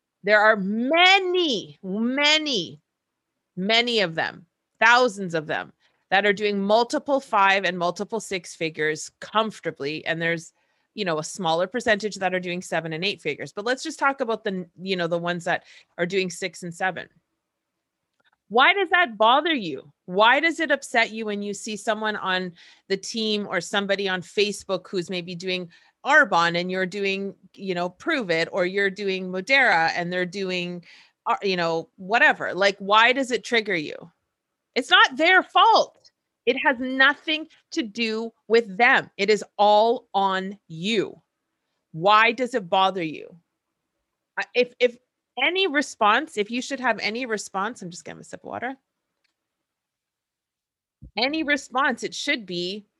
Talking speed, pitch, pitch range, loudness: 160 wpm, 205 Hz, 185-245 Hz, -22 LUFS